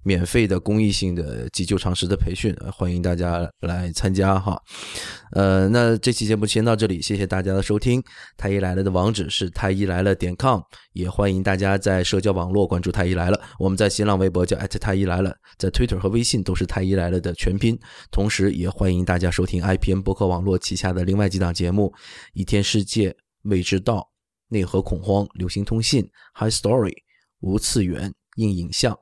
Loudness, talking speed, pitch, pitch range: -22 LUFS, 325 characters per minute, 95 Hz, 90-105 Hz